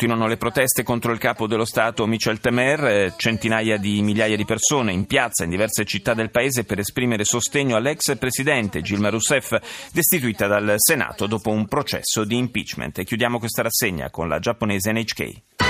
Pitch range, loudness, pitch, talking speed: 105-120 Hz, -21 LUFS, 115 Hz, 170 wpm